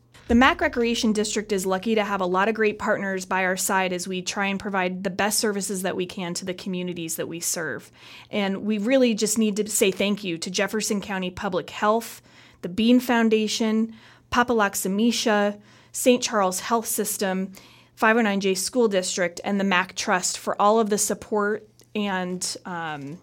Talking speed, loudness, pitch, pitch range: 180 wpm, -23 LUFS, 200 Hz, 185-220 Hz